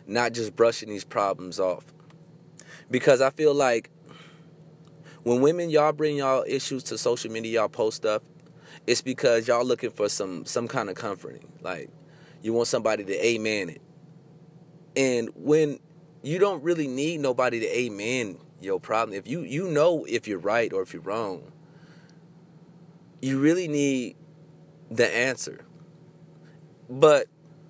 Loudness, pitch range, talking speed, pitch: -25 LUFS, 125-165 Hz, 145 wpm, 155 Hz